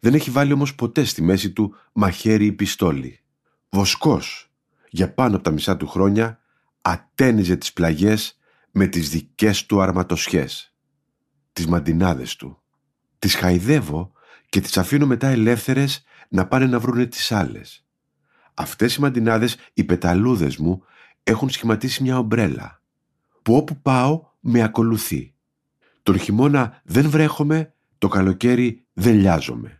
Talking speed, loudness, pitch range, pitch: 135 wpm, -20 LUFS, 95-135 Hz, 115 Hz